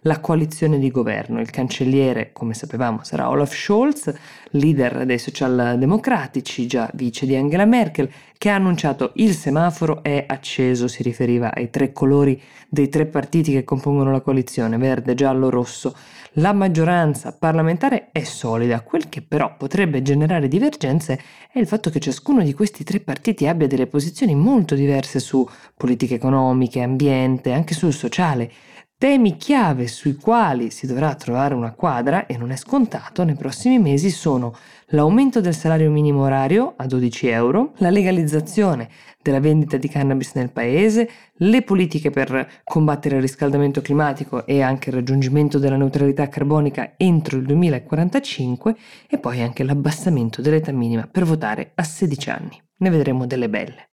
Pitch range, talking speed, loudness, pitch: 130-170 Hz, 155 wpm, -19 LUFS, 145 Hz